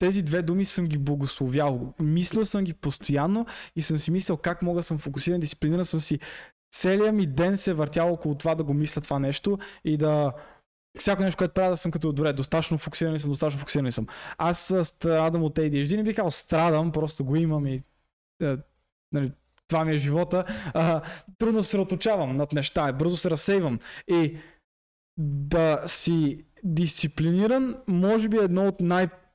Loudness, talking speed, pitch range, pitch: -26 LUFS, 180 wpm, 150-185 Hz, 165 Hz